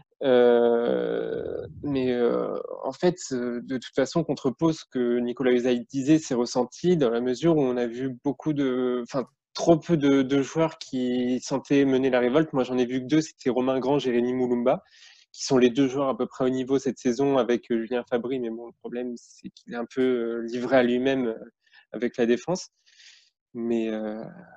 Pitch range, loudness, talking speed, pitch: 120-140 Hz, -25 LUFS, 195 wpm, 130 Hz